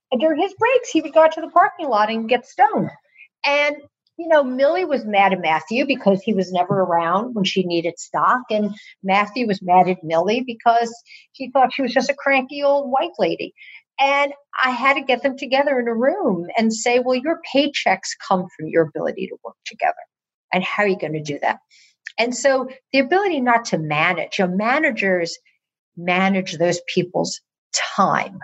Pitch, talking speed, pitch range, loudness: 245 Hz, 195 wpm, 190-280 Hz, -19 LUFS